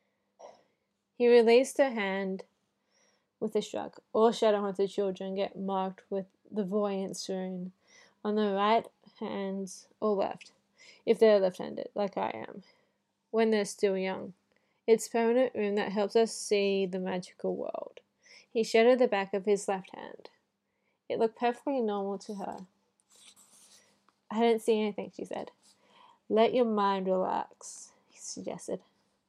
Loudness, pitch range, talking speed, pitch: -30 LUFS, 195-230 Hz, 145 wpm, 210 Hz